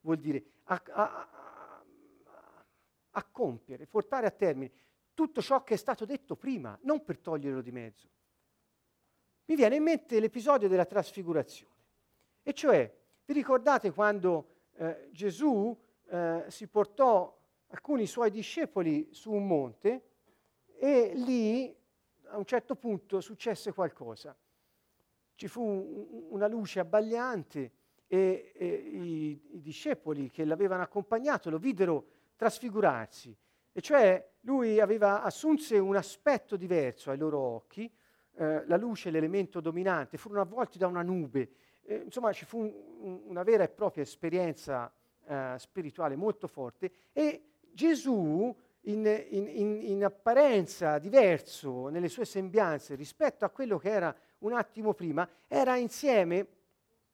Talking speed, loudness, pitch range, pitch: 135 wpm, -31 LUFS, 160-235 Hz, 200 Hz